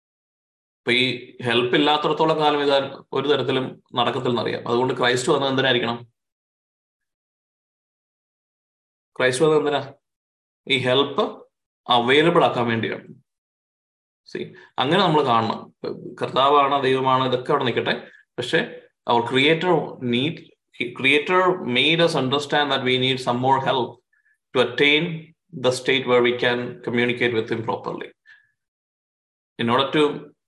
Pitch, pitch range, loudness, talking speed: 130 Hz, 120-145 Hz, -20 LUFS, 85 wpm